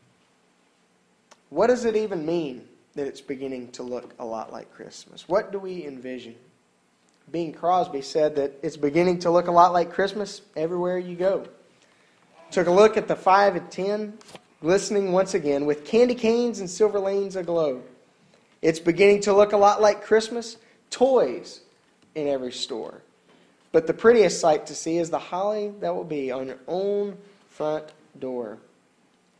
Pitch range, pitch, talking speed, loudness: 145-205 Hz, 175 Hz, 165 wpm, -23 LUFS